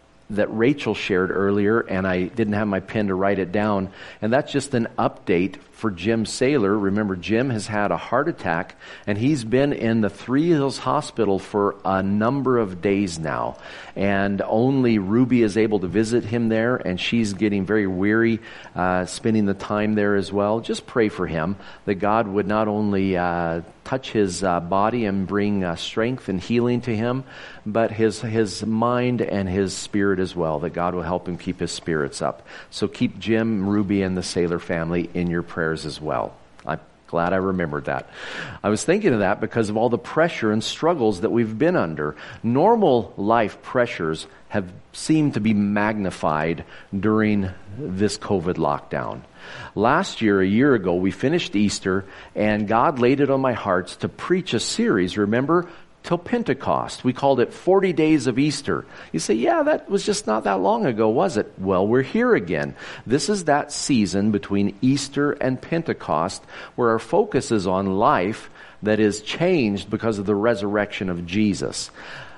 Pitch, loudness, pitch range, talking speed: 105 Hz, -22 LUFS, 95-120 Hz, 180 wpm